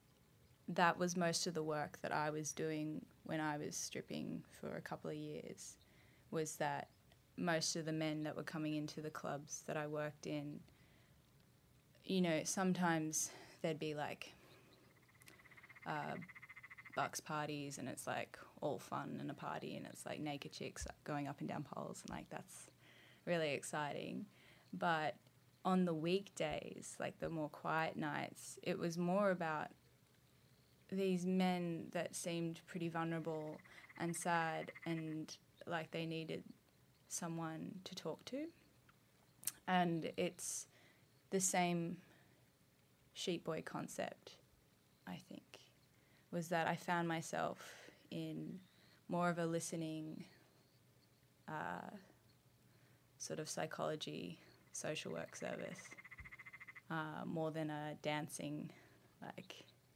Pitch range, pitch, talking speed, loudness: 150-170 Hz, 160 Hz, 130 wpm, -43 LUFS